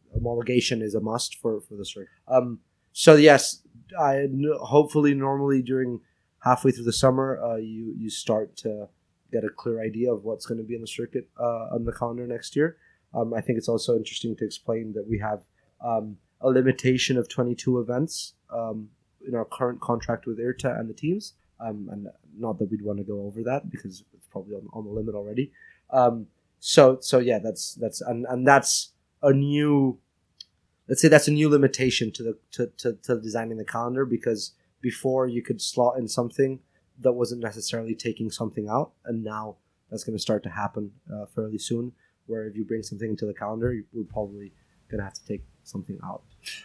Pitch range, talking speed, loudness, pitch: 110-130 Hz, 200 wpm, -25 LUFS, 115 Hz